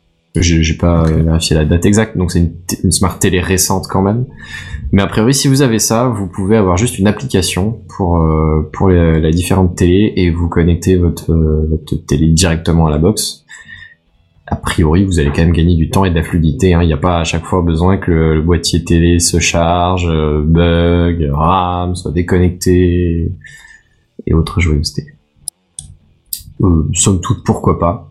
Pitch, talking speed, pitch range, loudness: 85 Hz, 190 wpm, 80-95 Hz, -12 LUFS